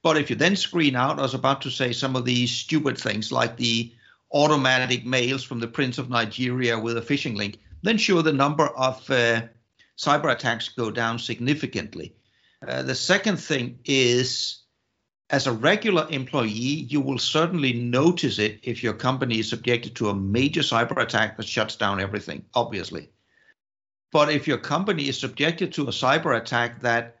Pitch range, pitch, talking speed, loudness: 115-145 Hz, 125 Hz, 175 wpm, -23 LUFS